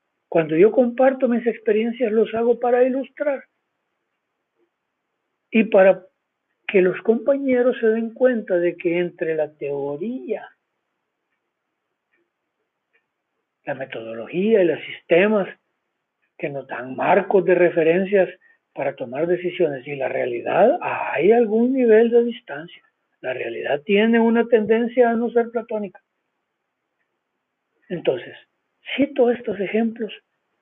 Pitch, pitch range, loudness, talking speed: 220 Hz, 175-240 Hz, -20 LUFS, 115 wpm